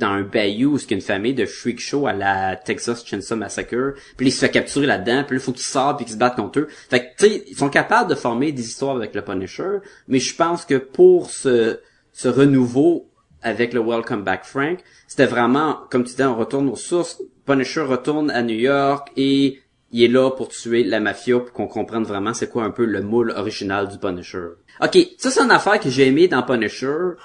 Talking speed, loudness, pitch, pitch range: 225 wpm, -19 LUFS, 125 Hz, 115-140 Hz